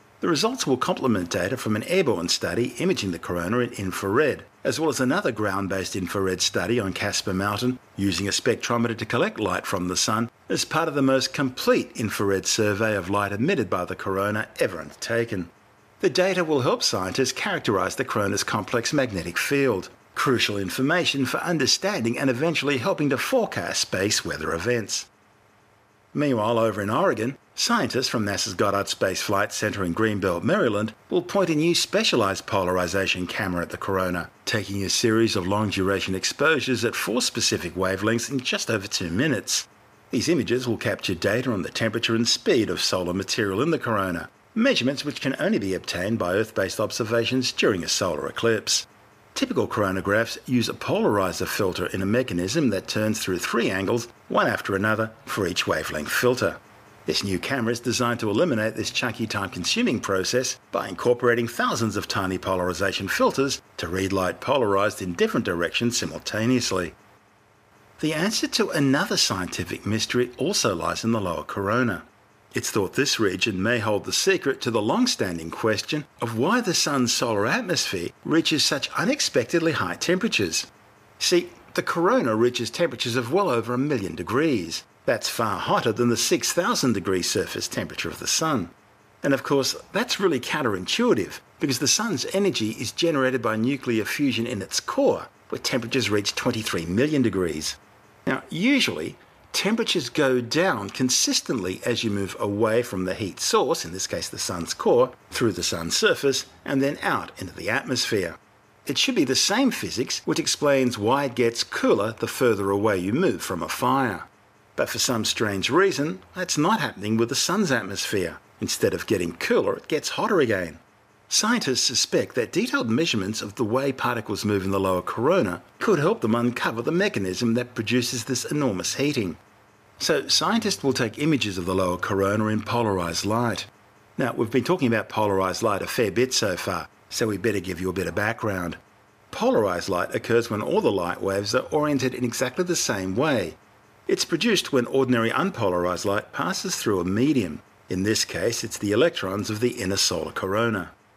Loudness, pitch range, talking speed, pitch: -24 LUFS, 100-130 Hz, 175 wpm, 115 Hz